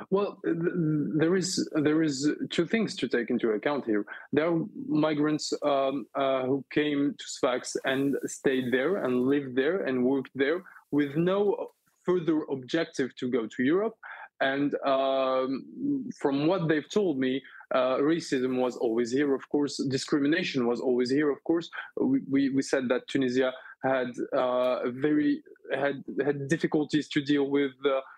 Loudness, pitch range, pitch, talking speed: -28 LUFS, 130-160 Hz, 145 Hz, 160 wpm